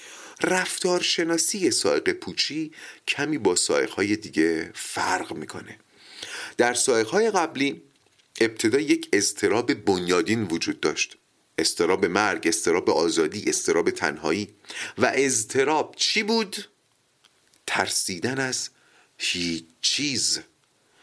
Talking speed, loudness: 100 wpm, -23 LUFS